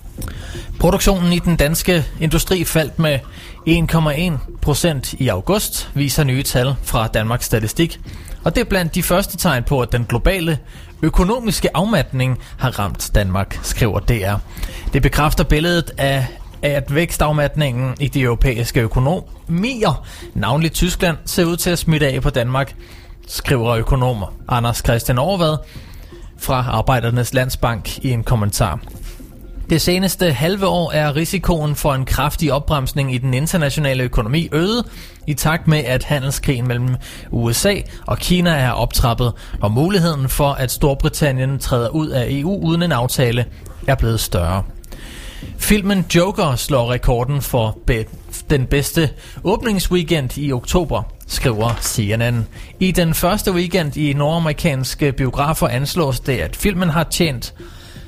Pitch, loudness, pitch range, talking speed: 140 Hz, -18 LUFS, 120-165 Hz, 135 wpm